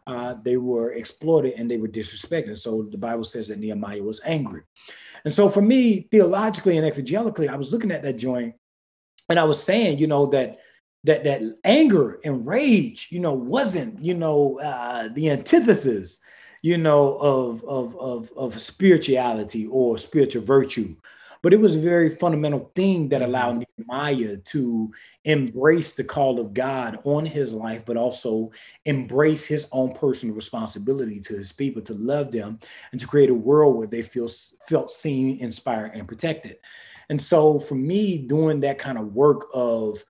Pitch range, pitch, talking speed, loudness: 115-155 Hz, 135 Hz, 170 wpm, -22 LUFS